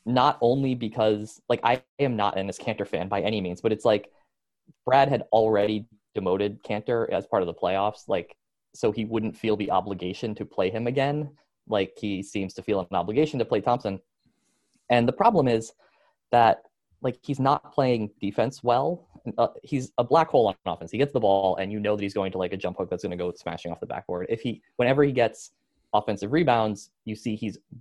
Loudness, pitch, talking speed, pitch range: -26 LUFS, 110 Hz, 210 wpm, 100-125 Hz